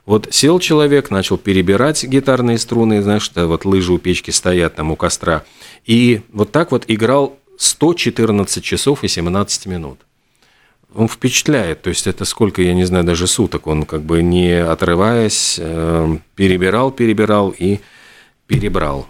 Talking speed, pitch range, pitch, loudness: 150 wpm, 90-115 Hz, 100 Hz, -15 LUFS